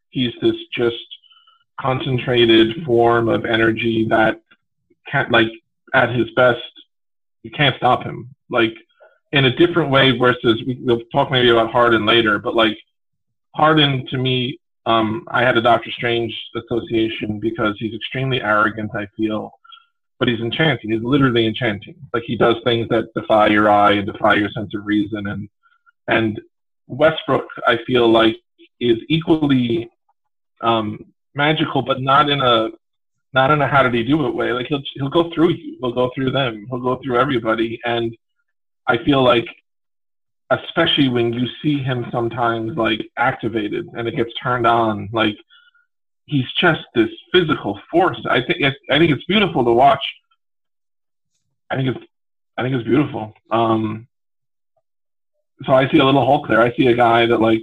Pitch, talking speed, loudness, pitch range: 120 Hz, 165 wpm, -17 LUFS, 115-145 Hz